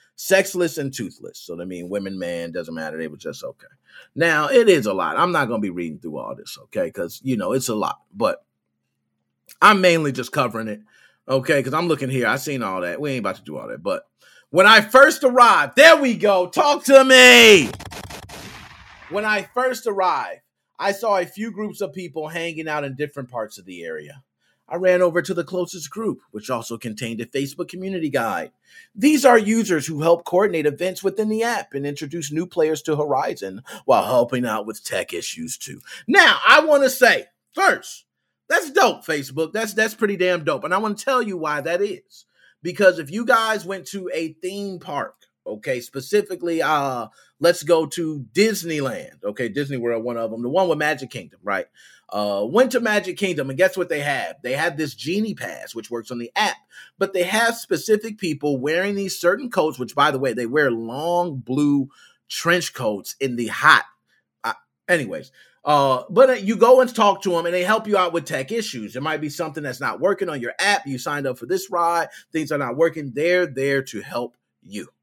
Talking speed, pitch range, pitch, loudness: 210 wpm, 135-210 Hz, 170 Hz, -19 LUFS